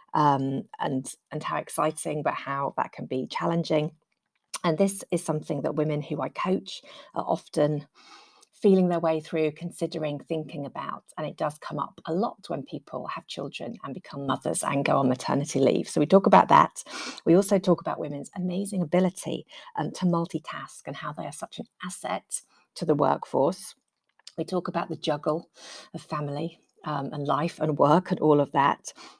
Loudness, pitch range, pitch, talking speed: -27 LUFS, 150-175 Hz, 160 Hz, 185 wpm